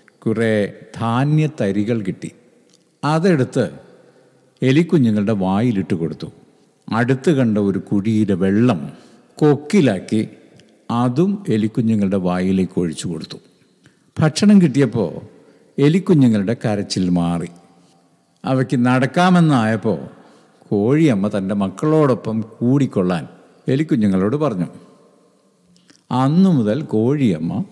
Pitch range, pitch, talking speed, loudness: 100-145 Hz, 115 Hz, 75 wpm, -18 LUFS